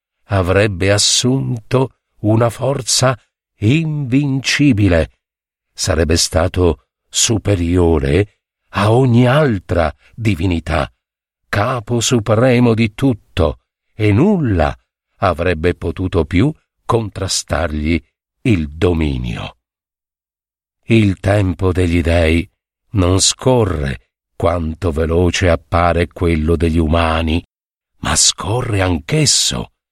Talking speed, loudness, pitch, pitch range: 80 wpm, -15 LUFS, 95 Hz, 85-115 Hz